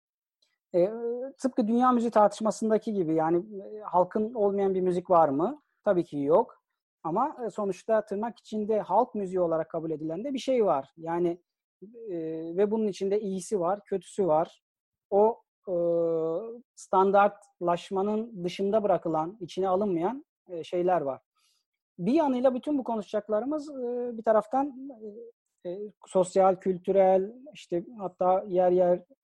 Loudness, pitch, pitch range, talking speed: -28 LUFS, 195 Hz, 180-225 Hz, 135 wpm